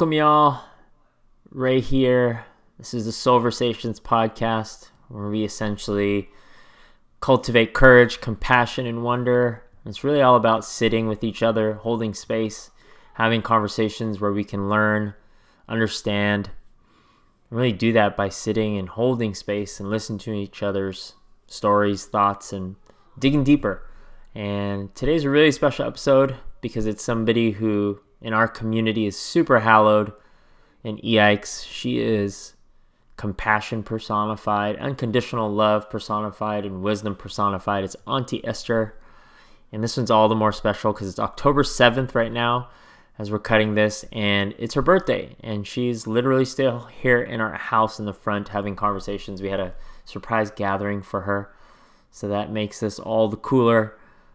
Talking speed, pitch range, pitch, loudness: 145 wpm, 105-120 Hz, 110 Hz, -22 LUFS